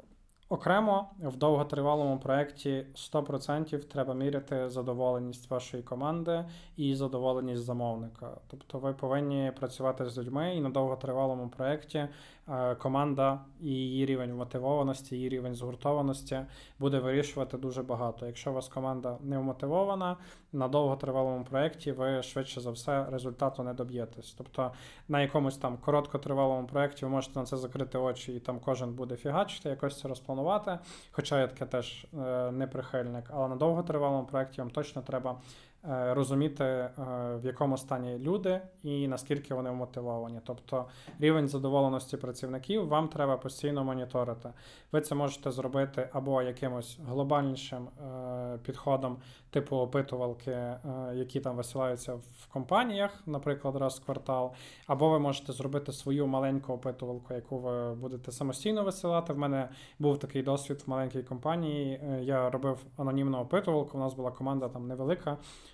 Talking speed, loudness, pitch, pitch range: 135 wpm, -33 LUFS, 135 Hz, 125-145 Hz